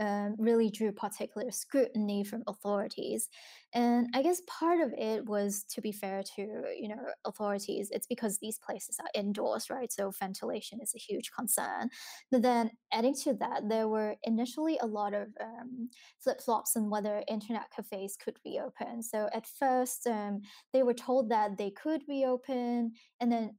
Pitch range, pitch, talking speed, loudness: 210-245 Hz, 225 Hz, 175 wpm, -34 LUFS